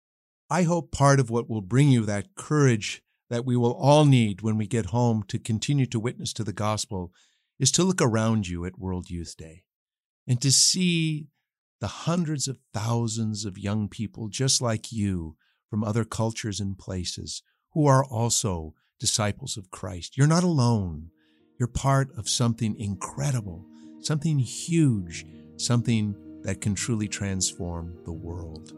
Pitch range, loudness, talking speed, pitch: 95-130 Hz, -25 LUFS, 160 wpm, 110 Hz